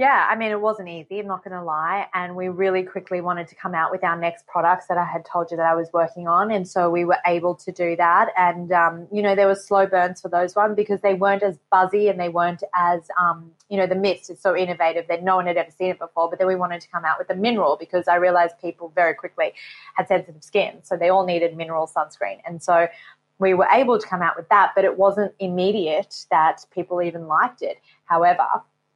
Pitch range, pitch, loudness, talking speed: 170-190 Hz, 180 Hz, -21 LUFS, 250 wpm